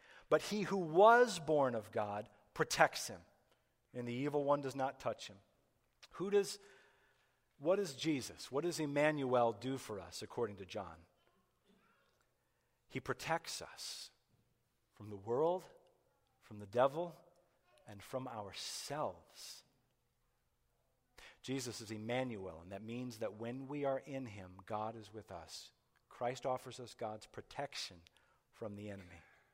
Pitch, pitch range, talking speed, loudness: 125 Hz, 105-145 Hz, 135 wpm, -39 LUFS